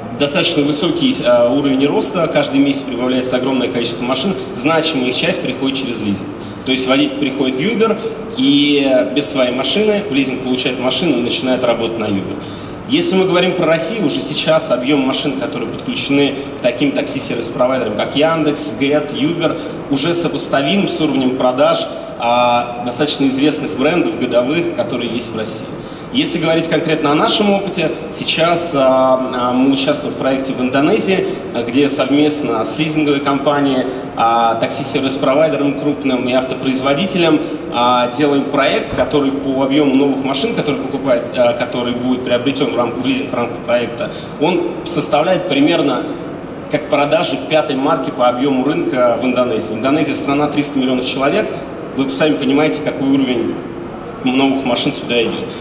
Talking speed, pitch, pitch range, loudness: 145 wpm, 140 Hz, 130-155 Hz, -15 LUFS